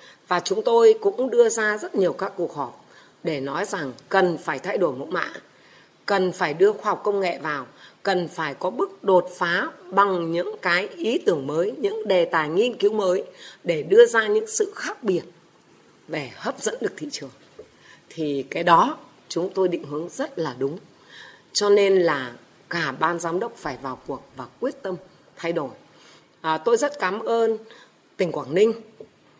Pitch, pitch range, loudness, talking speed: 190 Hz, 170-225 Hz, -23 LUFS, 185 wpm